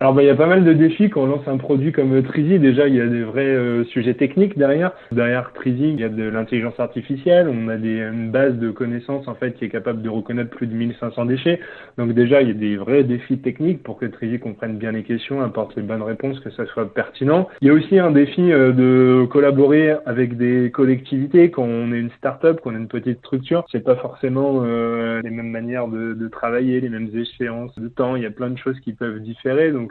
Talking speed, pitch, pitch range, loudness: 245 wpm, 125 Hz, 115-140 Hz, -19 LUFS